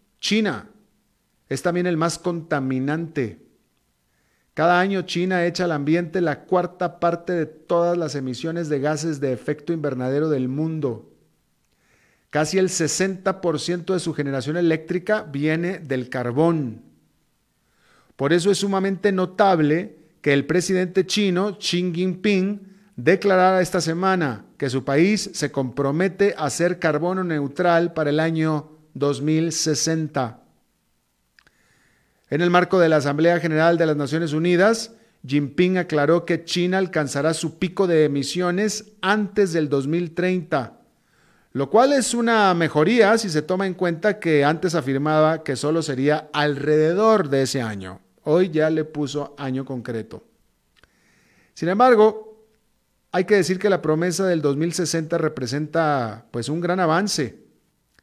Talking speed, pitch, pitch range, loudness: 130 wpm, 165 Hz, 150-185 Hz, -21 LUFS